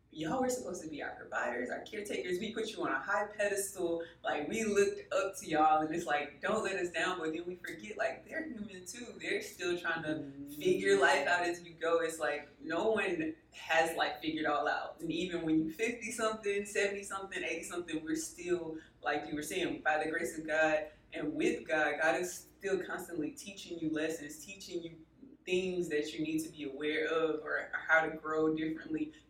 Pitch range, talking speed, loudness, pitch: 155-200 Hz, 210 wpm, -35 LUFS, 165 Hz